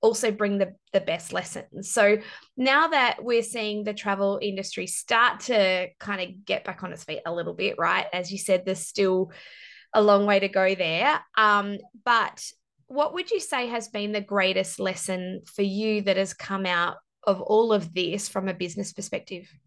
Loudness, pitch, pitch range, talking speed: -25 LUFS, 200 Hz, 190-220 Hz, 190 wpm